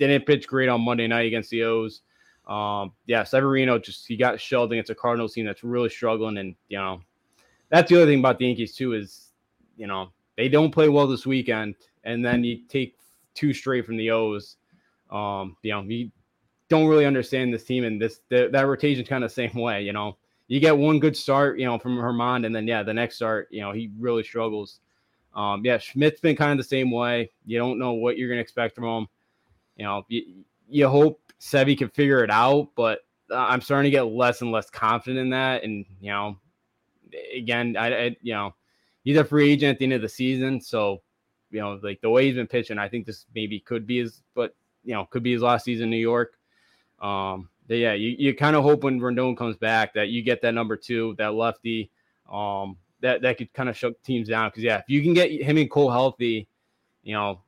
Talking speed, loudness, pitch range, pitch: 230 wpm, -23 LUFS, 110-130 Hz, 120 Hz